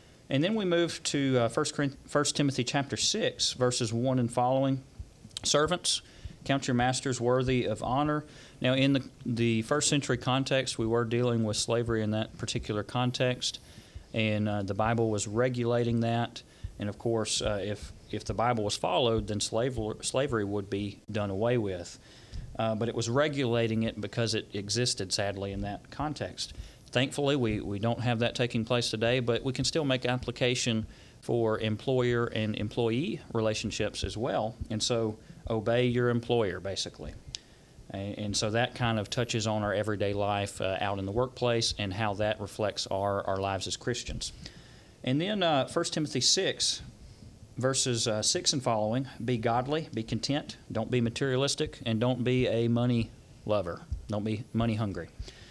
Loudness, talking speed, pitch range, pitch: -30 LUFS, 170 wpm, 105-125 Hz, 115 Hz